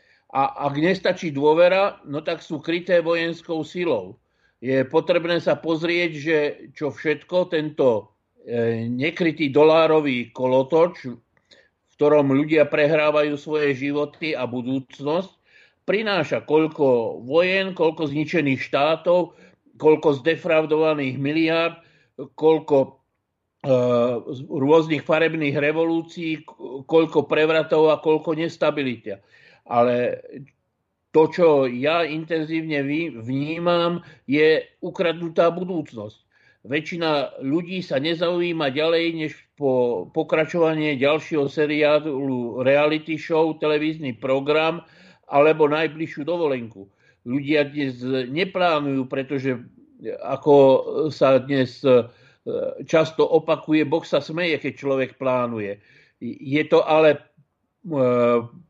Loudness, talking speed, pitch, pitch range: -21 LUFS, 95 wpm, 155 Hz, 135-165 Hz